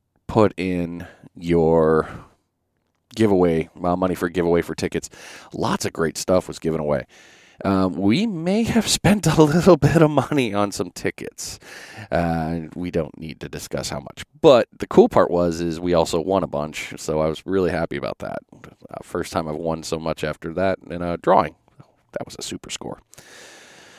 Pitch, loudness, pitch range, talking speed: 85 Hz, -21 LUFS, 80-100 Hz, 180 wpm